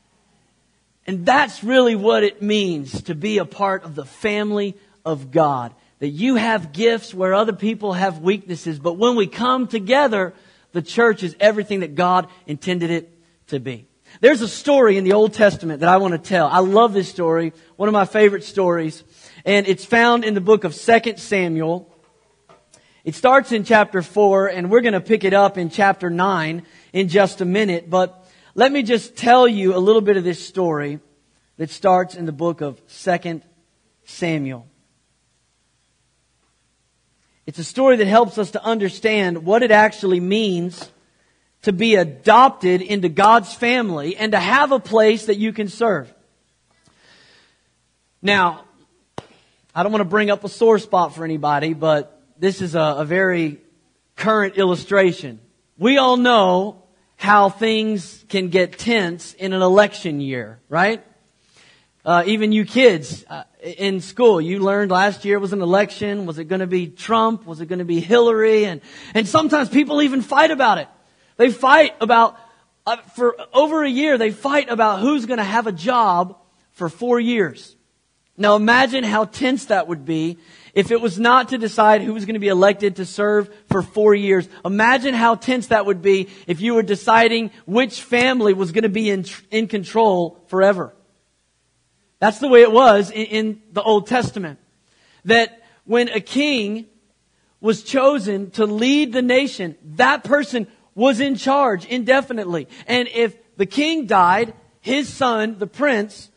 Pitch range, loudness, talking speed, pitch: 180-230 Hz, -17 LUFS, 170 wpm, 205 Hz